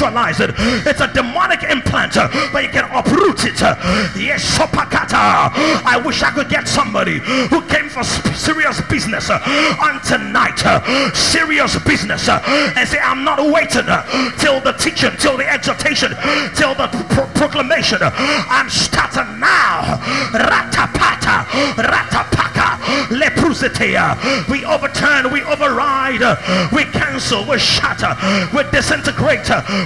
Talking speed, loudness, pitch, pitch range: 110 wpm, -14 LUFS, 290 Hz, 270-300 Hz